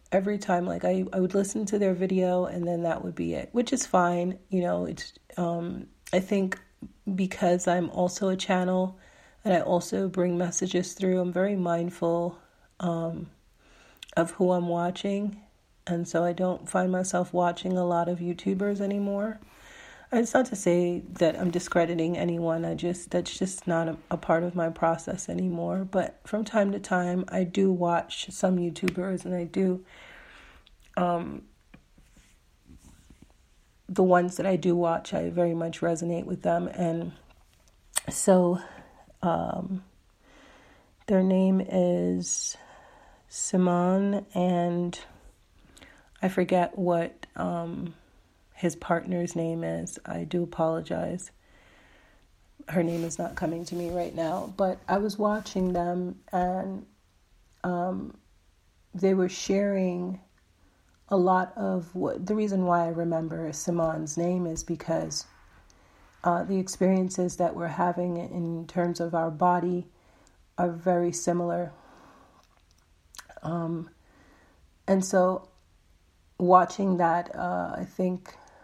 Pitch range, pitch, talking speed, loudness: 170-185 Hz, 175 Hz, 135 wpm, -28 LUFS